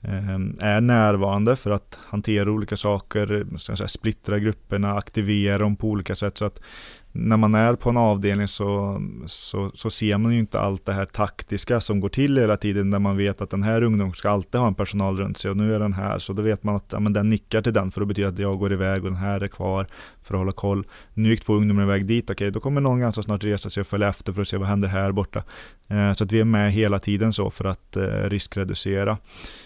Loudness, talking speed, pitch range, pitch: -23 LUFS, 245 wpm, 100-105 Hz, 100 Hz